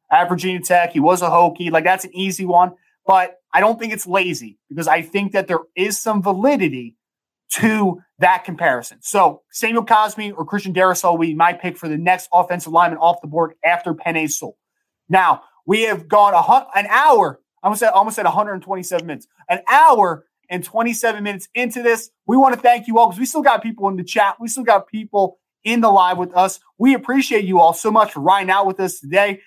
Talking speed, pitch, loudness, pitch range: 215 wpm, 190 Hz, -17 LUFS, 175-220 Hz